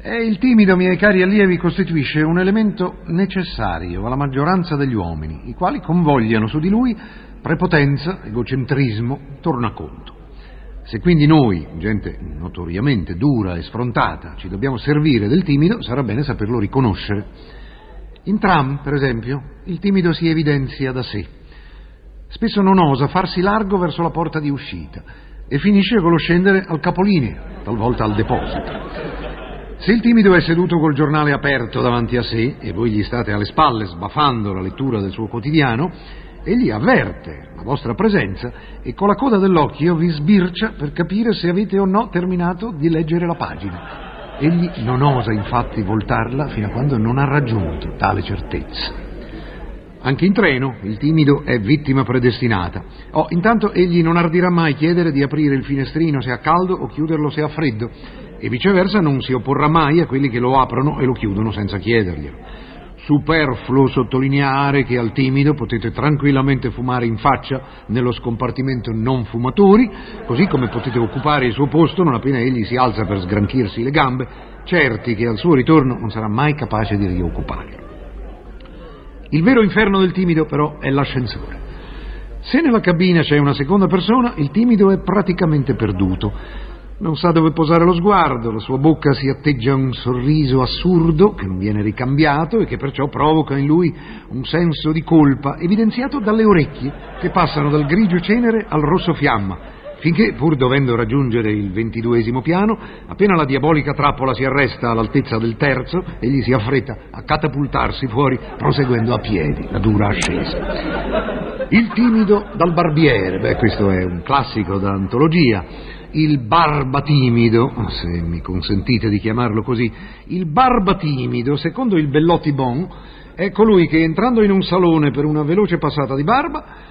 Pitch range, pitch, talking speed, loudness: 120-170 Hz, 140 Hz, 160 wpm, -17 LUFS